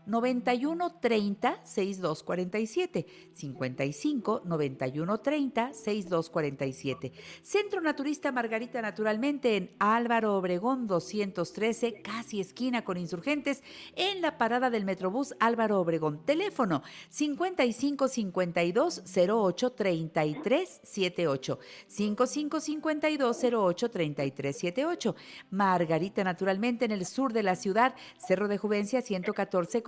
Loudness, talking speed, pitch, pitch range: -30 LUFS, 70 wpm, 215 Hz, 180-255 Hz